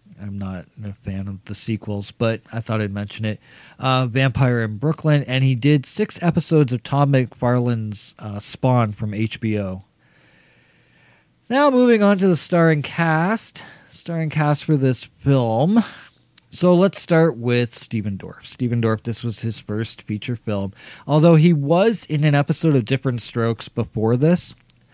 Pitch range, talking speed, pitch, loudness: 110-155 Hz, 160 wpm, 125 Hz, -20 LUFS